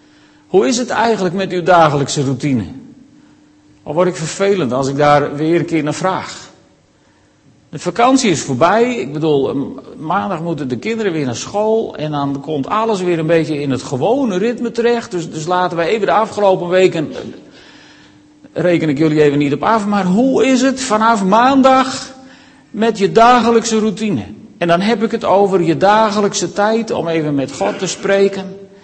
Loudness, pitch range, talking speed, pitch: -14 LUFS, 160-230 Hz, 175 wpm, 190 Hz